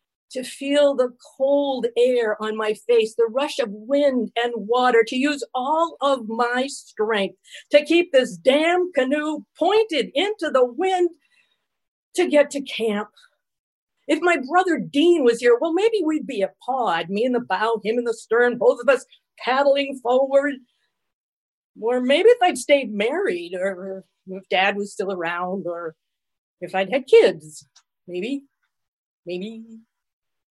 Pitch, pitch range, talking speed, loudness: 255 Hz, 215-300 Hz, 150 wpm, -21 LUFS